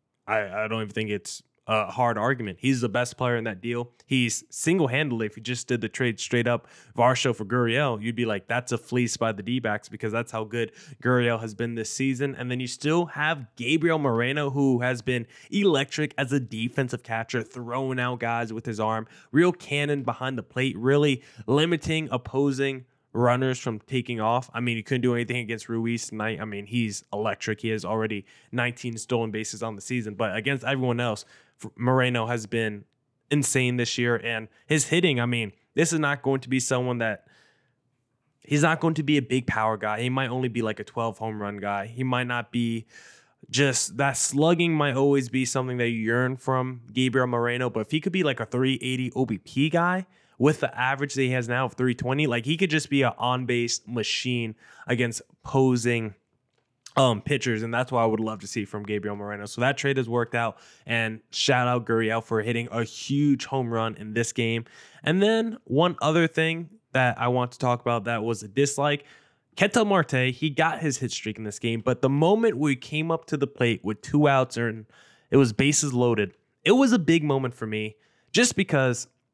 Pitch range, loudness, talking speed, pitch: 115-140 Hz, -25 LUFS, 205 wpm, 125 Hz